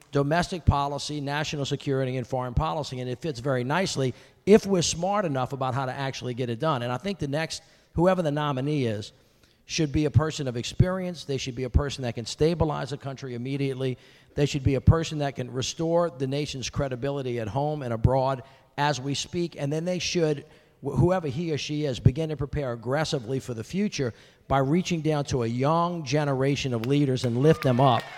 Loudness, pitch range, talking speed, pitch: -27 LUFS, 130-155 Hz, 205 wpm, 140 Hz